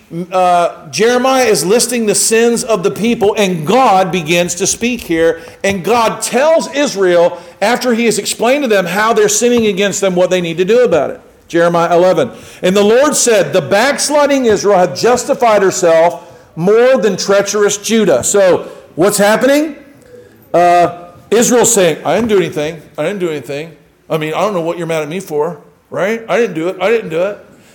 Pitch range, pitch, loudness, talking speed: 175-235 Hz, 200 Hz, -12 LUFS, 190 wpm